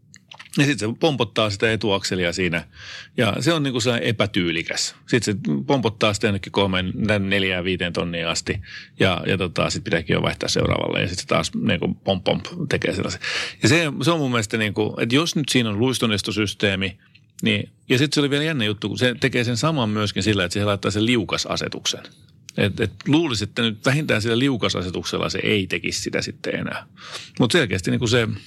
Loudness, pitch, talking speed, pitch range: -21 LUFS, 110 Hz, 195 wpm, 100-125 Hz